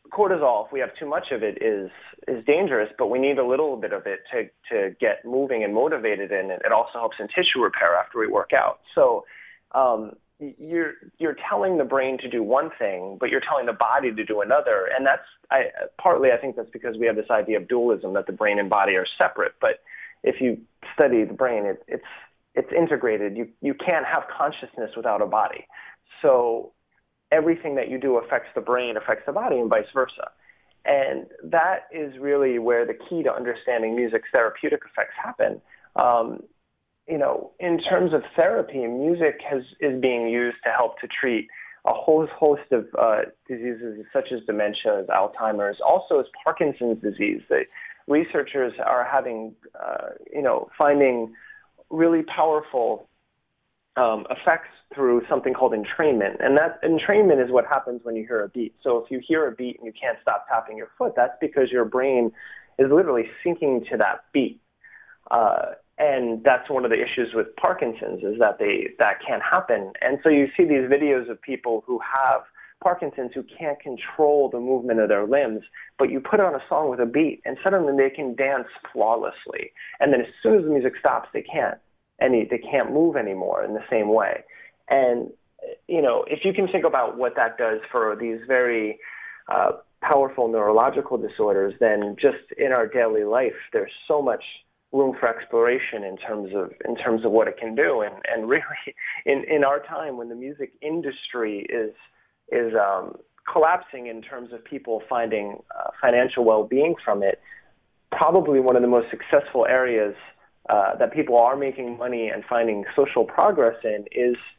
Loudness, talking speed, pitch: -23 LUFS, 185 wpm, 140 Hz